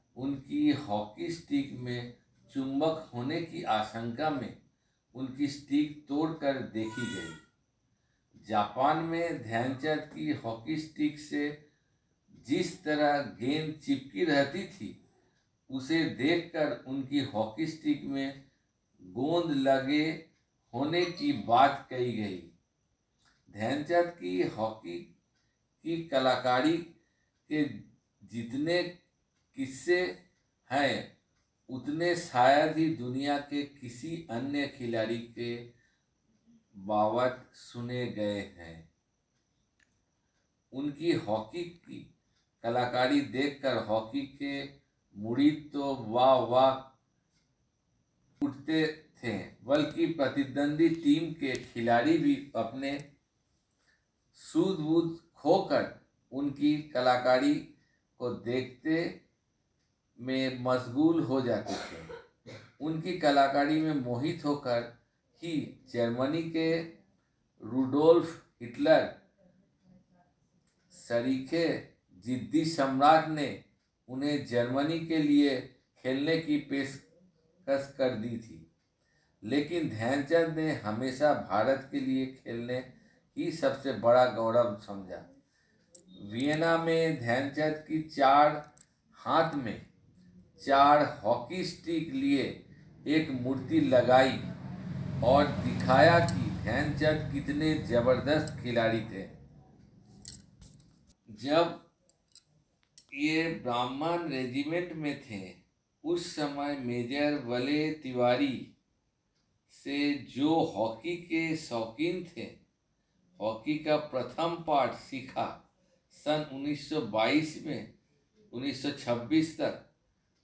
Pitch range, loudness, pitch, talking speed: 125-160 Hz, -30 LUFS, 140 Hz, 90 wpm